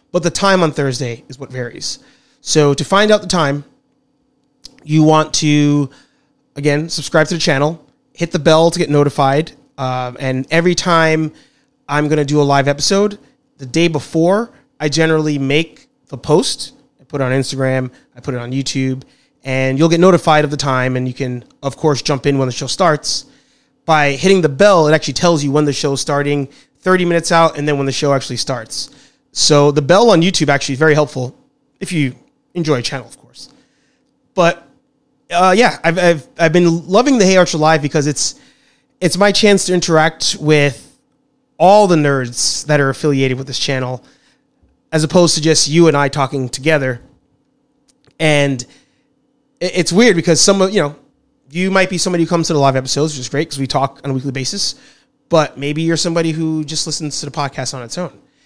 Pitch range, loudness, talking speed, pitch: 140-185 Hz, -14 LUFS, 195 wpm, 155 Hz